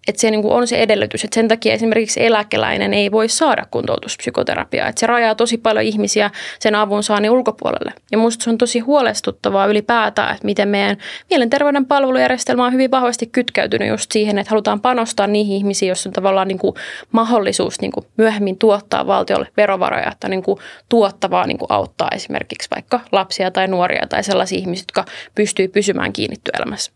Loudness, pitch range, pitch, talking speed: -16 LUFS, 200-235 Hz, 215 Hz, 180 wpm